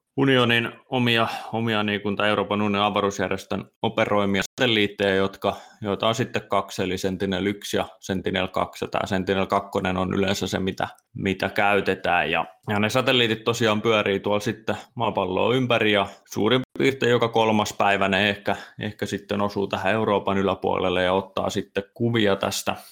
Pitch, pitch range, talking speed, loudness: 100 Hz, 95-110 Hz, 140 wpm, -23 LUFS